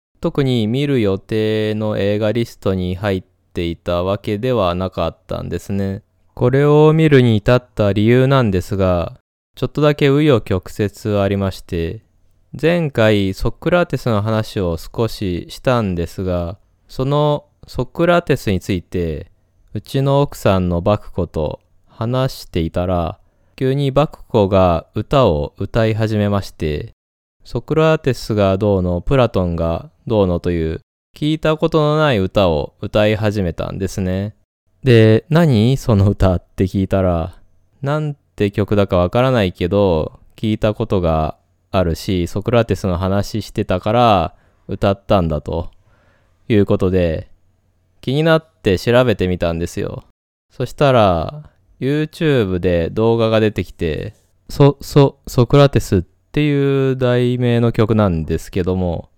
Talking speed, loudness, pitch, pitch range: 280 characters per minute, -17 LUFS, 105 Hz, 90-125 Hz